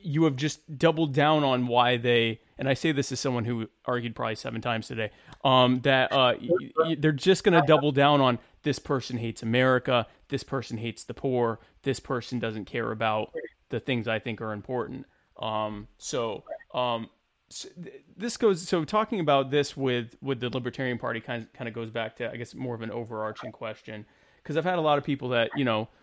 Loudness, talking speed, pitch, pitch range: -27 LUFS, 210 wpm, 125 Hz, 115-145 Hz